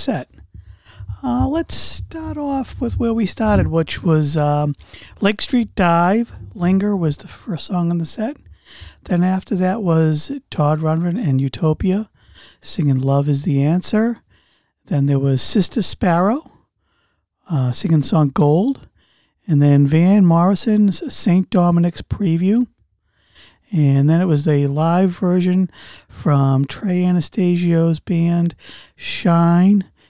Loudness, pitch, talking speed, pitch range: -17 LUFS, 170 Hz, 130 wpm, 150-195 Hz